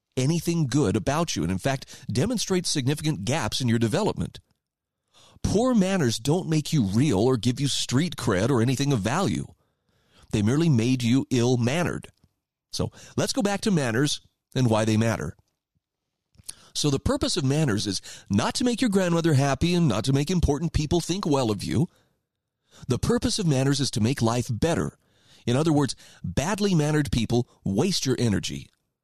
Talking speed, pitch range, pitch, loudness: 170 wpm, 115-160 Hz, 135 Hz, -25 LUFS